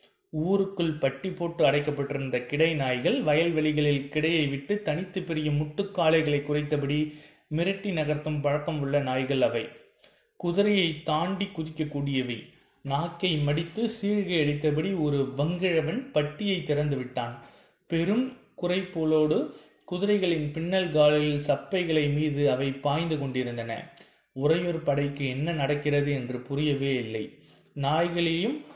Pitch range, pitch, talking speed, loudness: 145-170 Hz, 155 Hz, 100 wpm, -27 LUFS